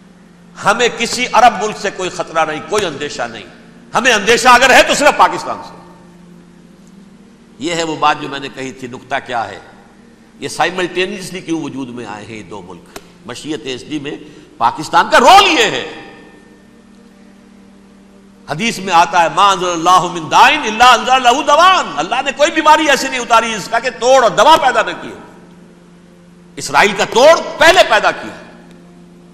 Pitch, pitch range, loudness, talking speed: 195 Hz, 165-230 Hz, -11 LUFS, 155 wpm